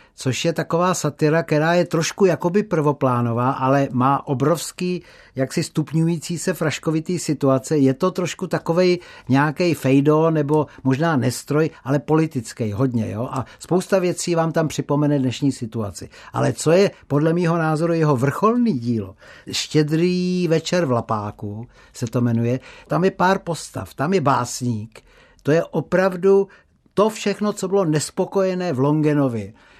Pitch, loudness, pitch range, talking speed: 155 Hz, -20 LUFS, 130-175 Hz, 145 wpm